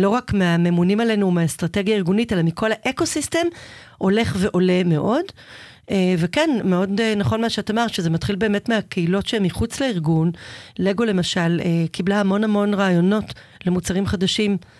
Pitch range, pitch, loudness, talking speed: 180-220 Hz, 195 Hz, -20 LUFS, 135 wpm